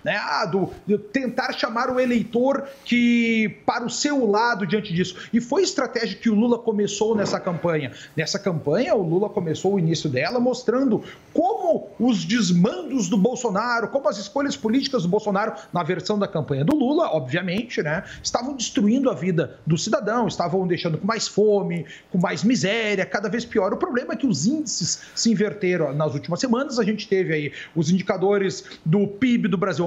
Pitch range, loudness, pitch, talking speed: 185-240 Hz, -22 LUFS, 210 Hz, 185 wpm